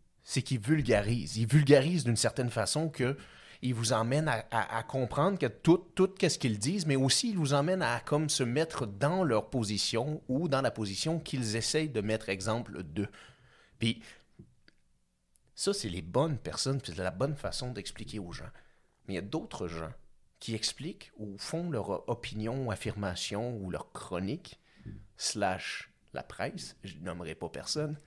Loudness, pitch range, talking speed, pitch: -32 LUFS, 105-145 Hz, 175 wpm, 120 Hz